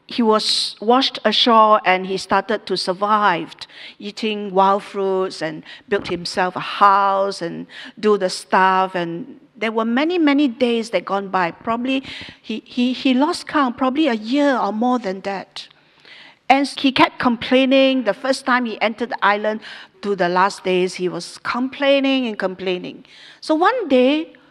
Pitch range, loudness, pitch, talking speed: 195-265 Hz, -18 LUFS, 220 Hz, 160 wpm